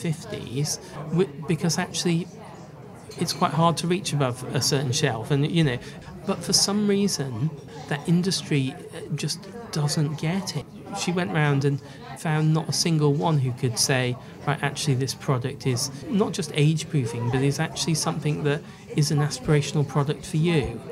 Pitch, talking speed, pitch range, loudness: 150 Hz, 165 wpm, 145-170 Hz, -25 LUFS